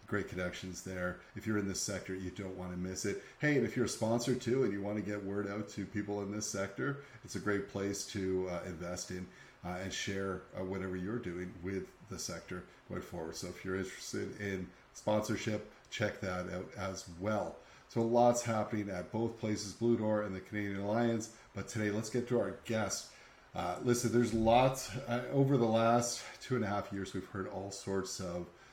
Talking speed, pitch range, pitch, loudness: 210 wpm, 95-115 Hz, 100 Hz, -36 LUFS